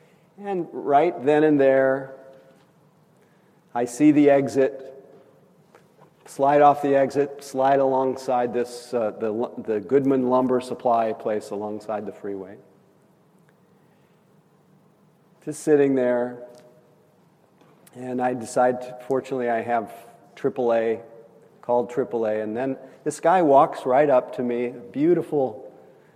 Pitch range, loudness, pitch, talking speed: 120-150 Hz, -22 LUFS, 135 Hz, 110 wpm